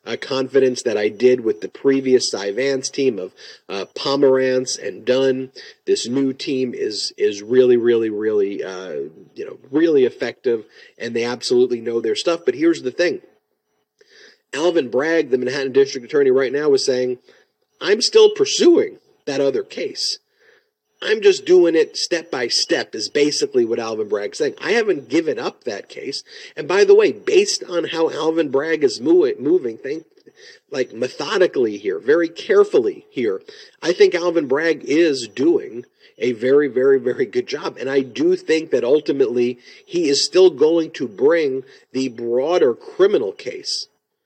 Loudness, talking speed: -18 LUFS, 165 wpm